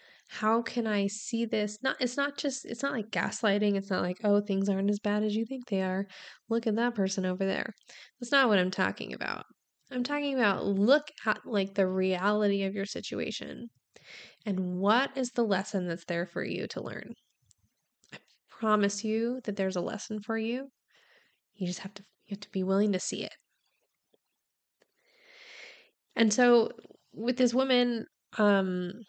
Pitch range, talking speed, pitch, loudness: 195-245 Hz, 180 wpm, 215 Hz, -30 LUFS